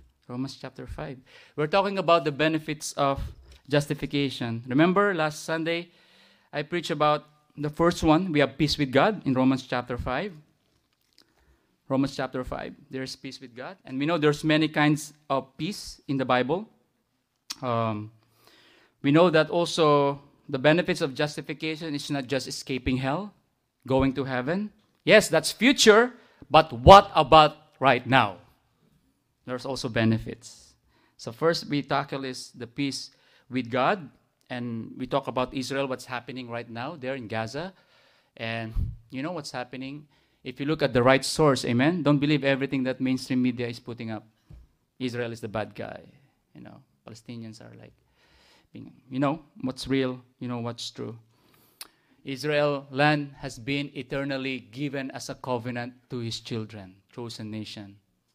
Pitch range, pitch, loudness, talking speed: 125-150 Hz, 135 Hz, -25 LUFS, 155 wpm